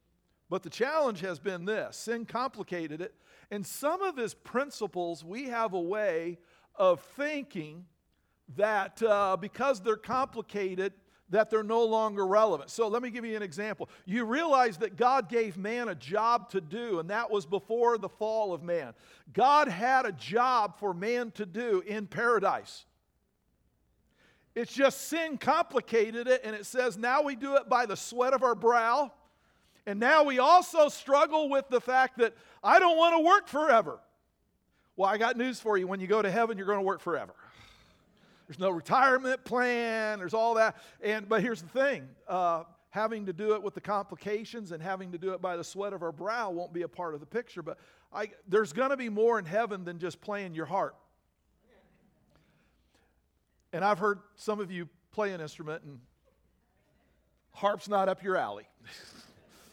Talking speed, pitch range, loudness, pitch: 180 wpm, 190-240 Hz, -29 LUFS, 215 Hz